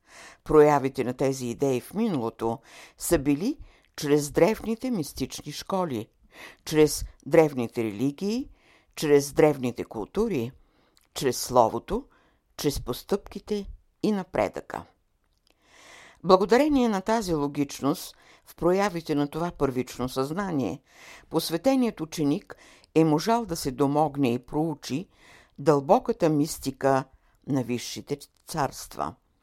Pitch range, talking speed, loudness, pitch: 135-190 Hz, 100 wpm, -26 LUFS, 150 Hz